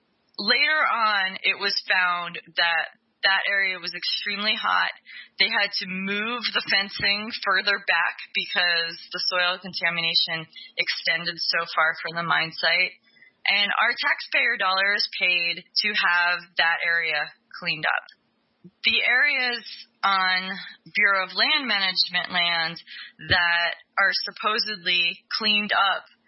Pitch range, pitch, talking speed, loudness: 170-205 Hz, 185 Hz, 125 wpm, -22 LUFS